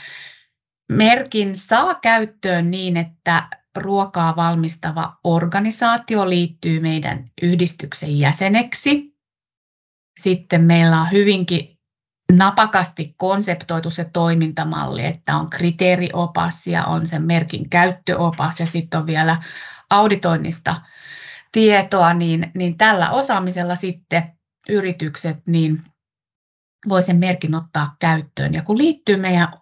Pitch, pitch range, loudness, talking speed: 175 Hz, 165-195 Hz, -18 LUFS, 100 wpm